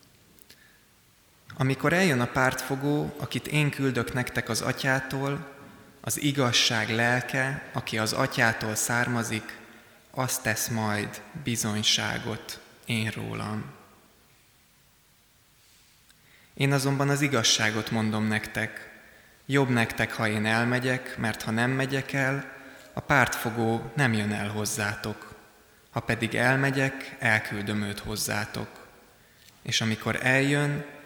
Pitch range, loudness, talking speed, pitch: 110-135 Hz, -26 LUFS, 105 wpm, 120 Hz